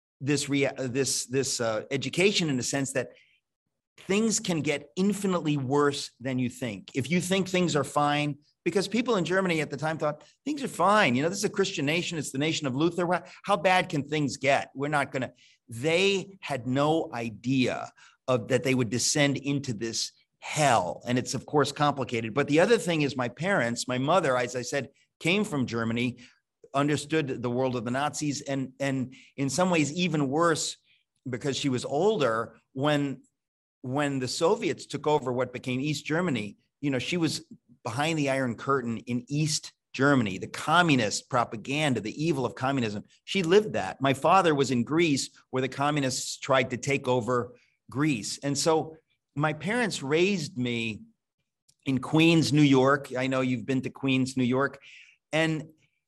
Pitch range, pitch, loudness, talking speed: 130-160 Hz, 140 Hz, -27 LUFS, 180 wpm